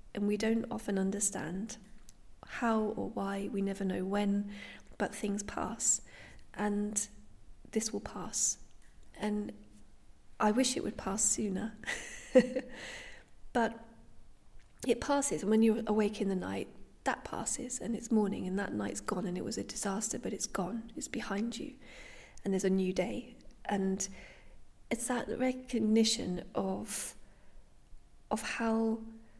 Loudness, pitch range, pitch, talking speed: -34 LUFS, 195-230 Hz, 210 Hz, 140 wpm